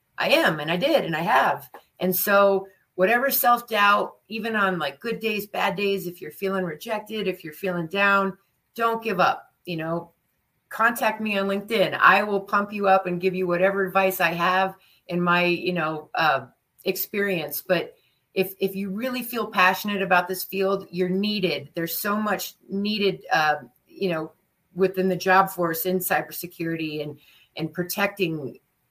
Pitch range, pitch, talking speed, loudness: 175-200 Hz, 190 Hz, 170 wpm, -23 LUFS